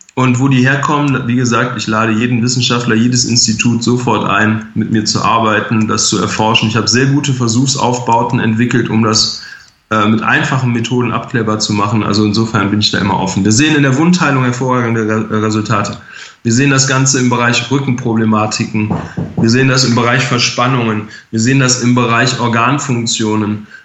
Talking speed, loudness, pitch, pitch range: 175 wpm, -12 LUFS, 120 Hz, 110-125 Hz